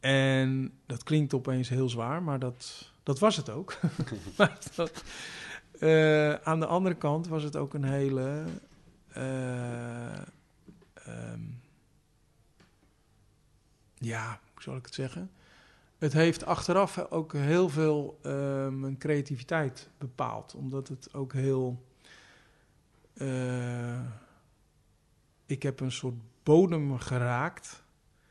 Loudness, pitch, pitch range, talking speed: -30 LUFS, 135 Hz, 125-155 Hz, 110 wpm